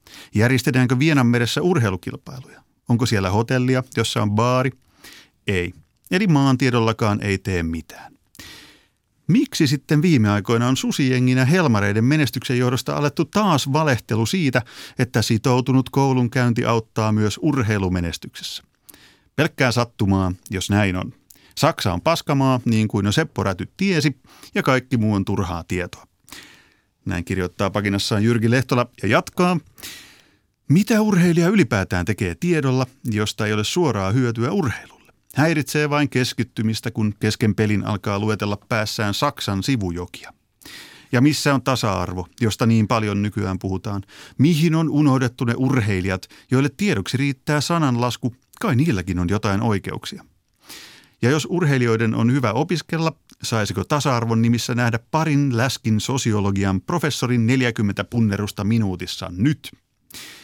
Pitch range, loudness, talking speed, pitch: 105-140 Hz, -20 LUFS, 120 wpm, 120 Hz